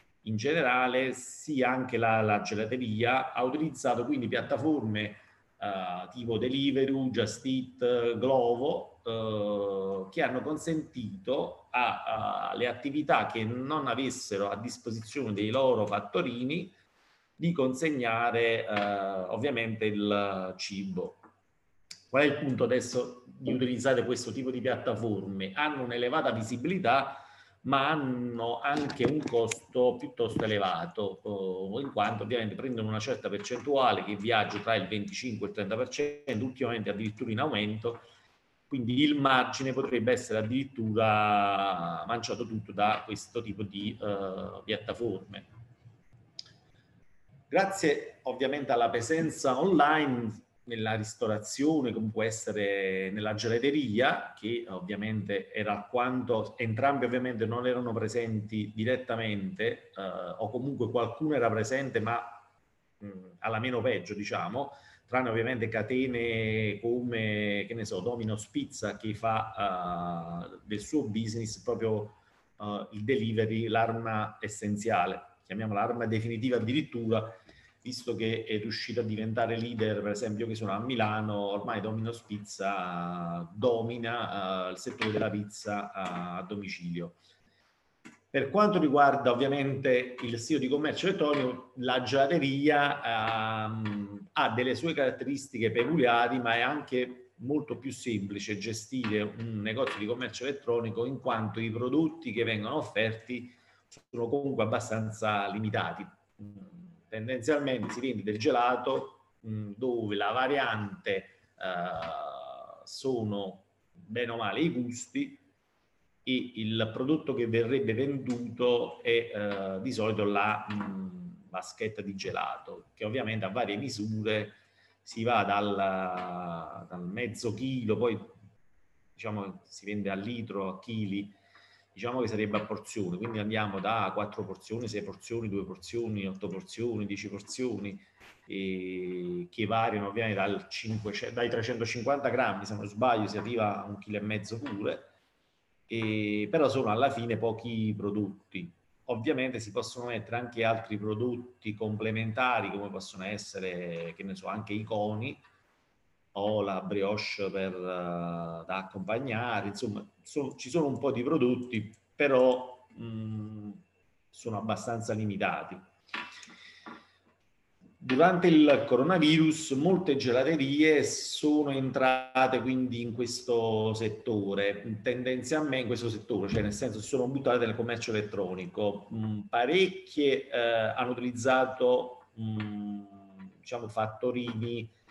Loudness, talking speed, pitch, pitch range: -31 LUFS, 125 wpm, 115 Hz, 105-125 Hz